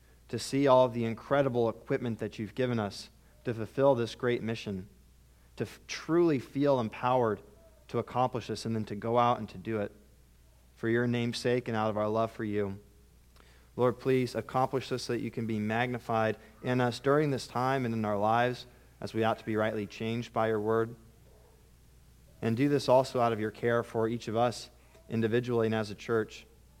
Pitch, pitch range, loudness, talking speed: 115 Hz, 105-125 Hz, -31 LUFS, 200 wpm